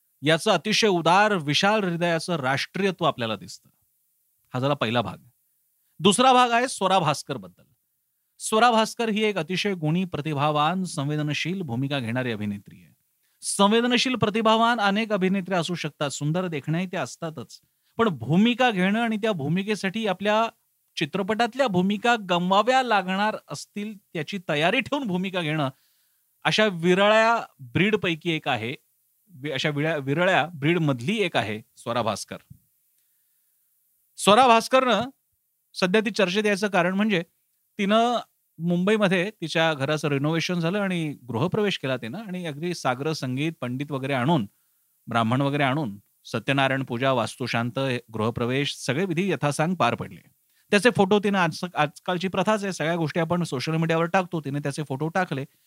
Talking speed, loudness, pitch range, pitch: 135 wpm, -24 LUFS, 145-205 Hz, 175 Hz